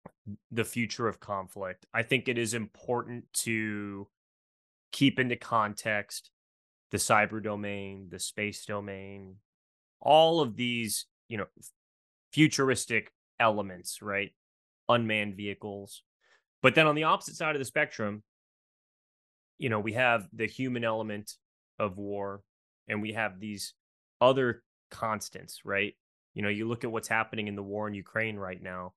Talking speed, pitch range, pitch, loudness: 140 wpm, 100-120 Hz, 105 Hz, -30 LUFS